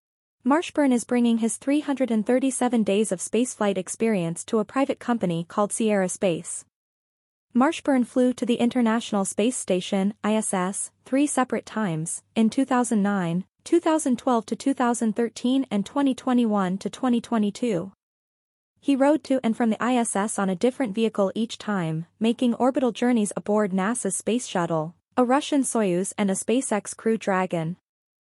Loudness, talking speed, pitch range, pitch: -24 LUFS, 135 wpm, 200-250 Hz, 225 Hz